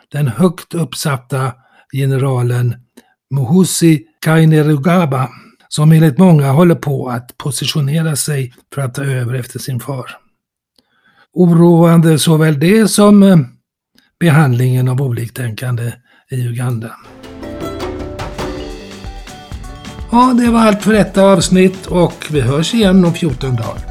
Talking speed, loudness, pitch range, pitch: 110 wpm, -12 LUFS, 125-170 Hz, 150 Hz